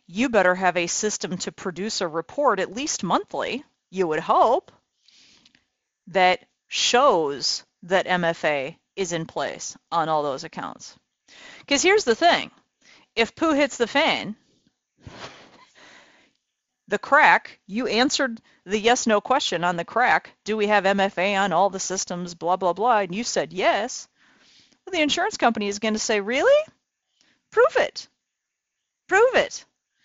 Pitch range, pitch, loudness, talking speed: 185-270 Hz, 210 Hz, -22 LUFS, 150 wpm